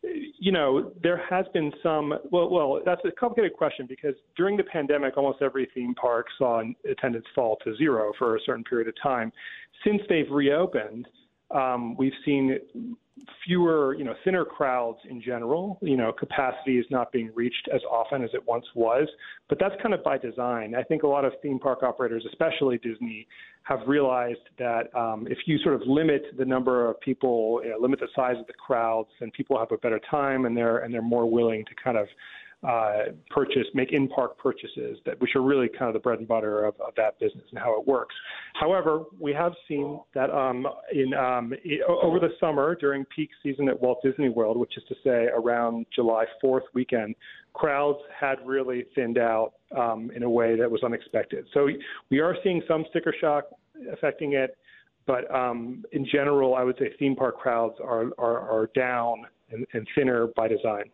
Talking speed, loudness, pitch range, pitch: 200 wpm, -26 LUFS, 120-150 Hz, 130 Hz